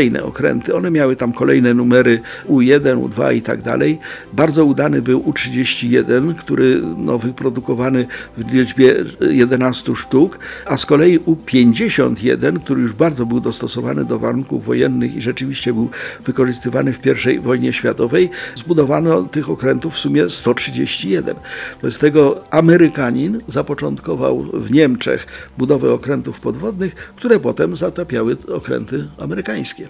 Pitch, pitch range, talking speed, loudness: 130 Hz, 125-155 Hz, 125 wpm, -16 LUFS